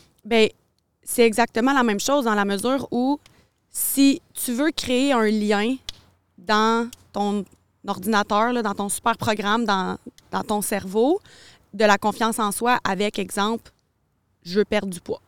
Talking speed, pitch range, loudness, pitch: 155 wpm, 205-240 Hz, -22 LUFS, 220 Hz